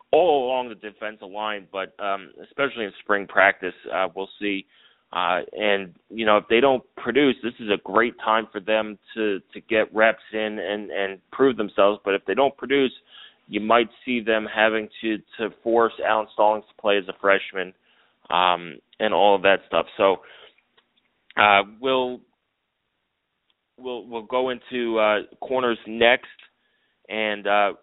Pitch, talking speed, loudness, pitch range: 110 Hz, 165 wpm, -22 LUFS, 100-115 Hz